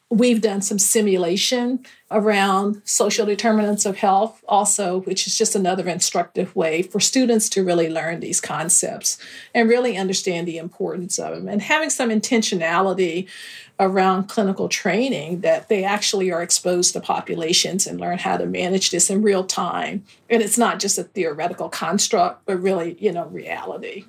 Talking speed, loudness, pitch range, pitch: 160 wpm, -20 LUFS, 180-220 Hz, 195 Hz